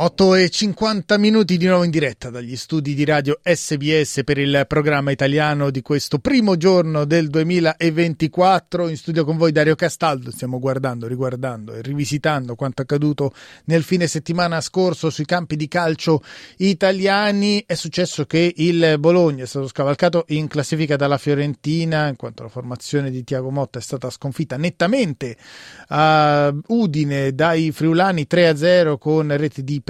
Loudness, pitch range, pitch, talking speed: -18 LUFS, 140-170 Hz, 155 Hz, 155 wpm